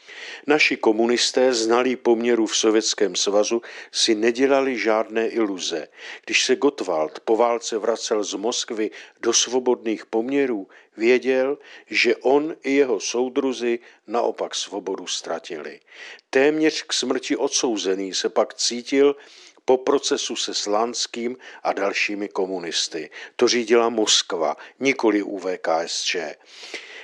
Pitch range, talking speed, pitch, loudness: 115-140 Hz, 110 wpm, 120 Hz, -21 LUFS